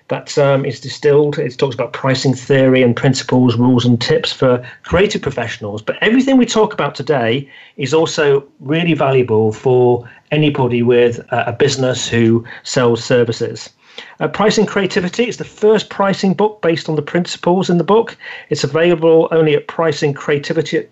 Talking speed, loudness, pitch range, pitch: 165 wpm, -15 LUFS, 125-165 Hz, 145 Hz